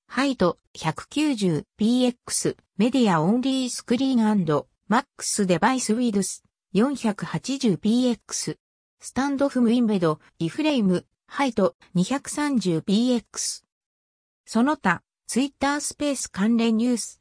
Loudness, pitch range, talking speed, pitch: -24 LUFS, 200-265 Hz, 245 characters per minute, 235 Hz